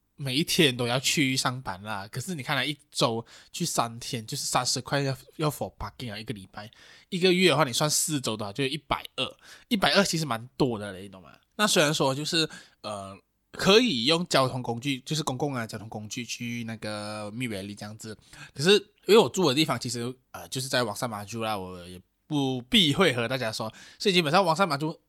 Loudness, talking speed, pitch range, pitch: -26 LUFS, 330 characters per minute, 110-155 Hz, 130 Hz